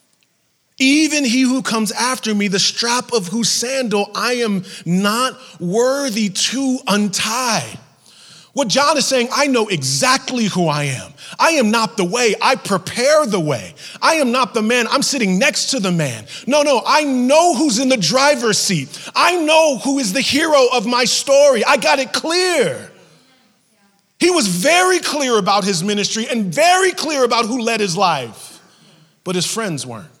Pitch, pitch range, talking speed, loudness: 245 Hz, 200-280 Hz, 175 wpm, -15 LUFS